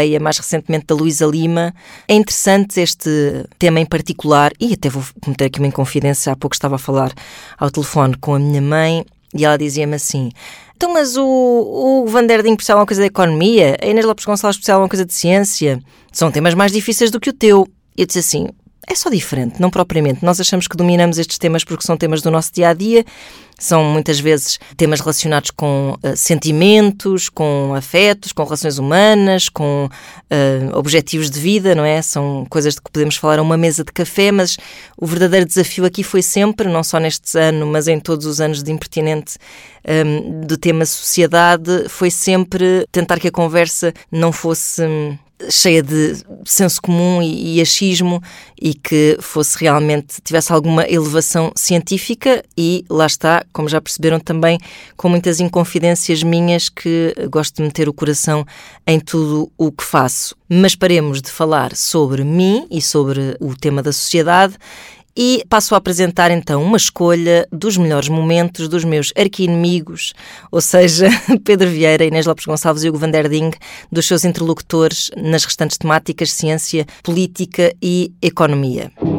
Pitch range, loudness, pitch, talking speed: 155-185 Hz, -14 LUFS, 165 Hz, 170 wpm